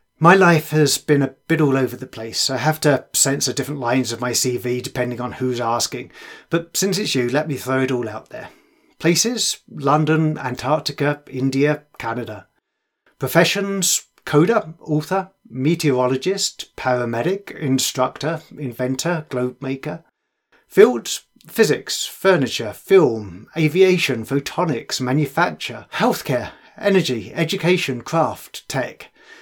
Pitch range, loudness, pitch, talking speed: 125-165 Hz, -19 LUFS, 145 Hz, 120 wpm